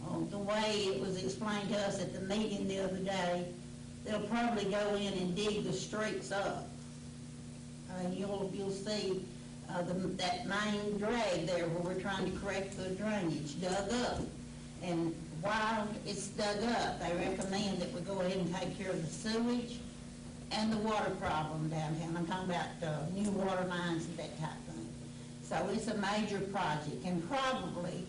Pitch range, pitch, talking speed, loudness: 175-205 Hz, 190 Hz, 180 wpm, -37 LUFS